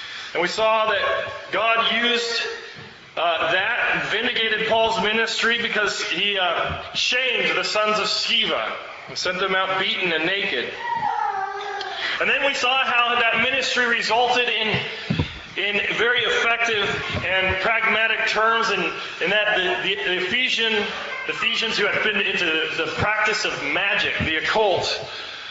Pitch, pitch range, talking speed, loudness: 225 Hz, 215-250 Hz, 145 wpm, -20 LUFS